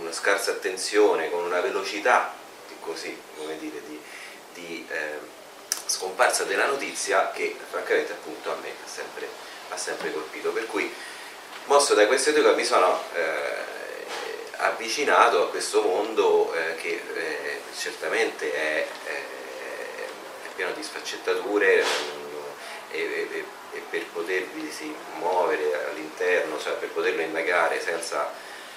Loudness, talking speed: -26 LUFS, 115 wpm